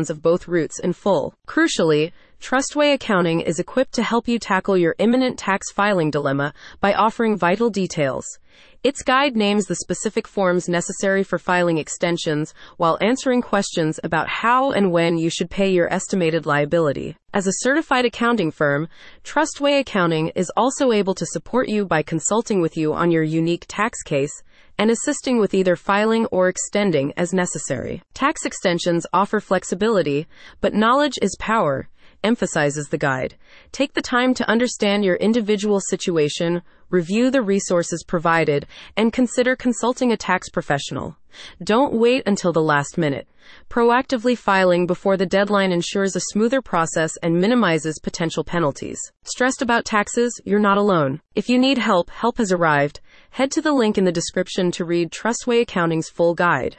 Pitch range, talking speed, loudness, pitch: 170-235 Hz, 160 wpm, -20 LUFS, 190 Hz